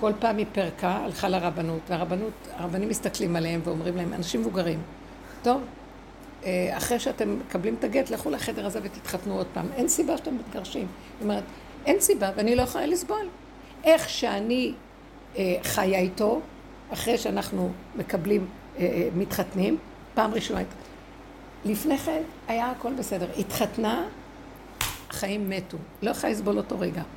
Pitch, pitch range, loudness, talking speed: 205 Hz, 180-255 Hz, -28 LUFS, 135 wpm